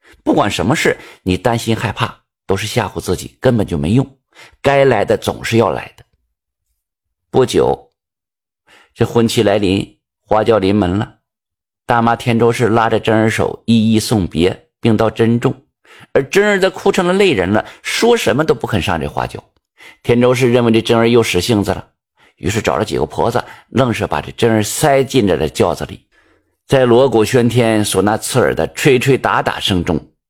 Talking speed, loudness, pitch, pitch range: 255 characters per minute, -14 LUFS, 115 Hz, 100-120 Hz